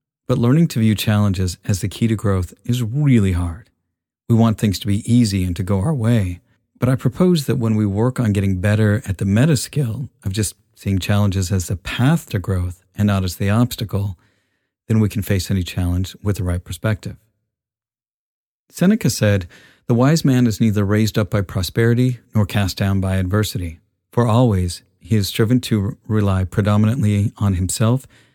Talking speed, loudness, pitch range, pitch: 185 wpm, -19 LUFS, 95-120 Hz, 105 Hz